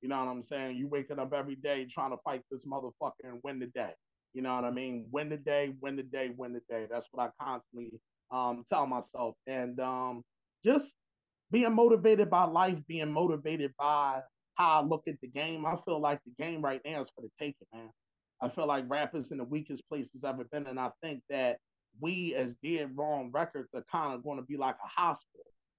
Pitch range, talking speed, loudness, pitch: 130-155 Hz, 225 wpm, -34 LUFS, 140 Hz